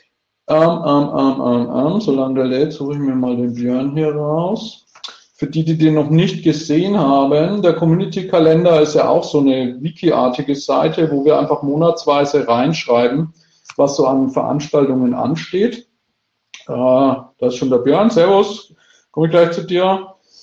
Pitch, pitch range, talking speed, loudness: 150 Hz, 135-170 Hz, 165 wpm, -15 LUFS